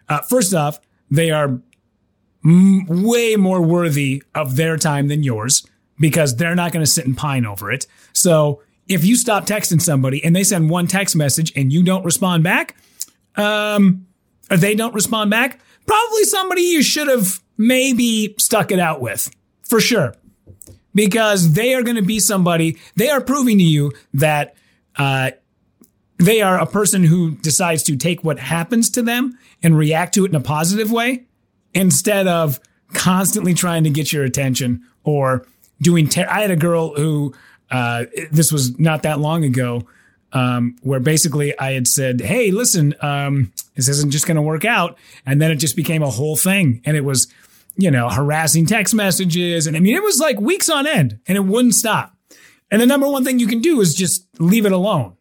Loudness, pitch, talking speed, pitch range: -16 LUFS, 165 Hz, 190 wpm, 145-205 Hz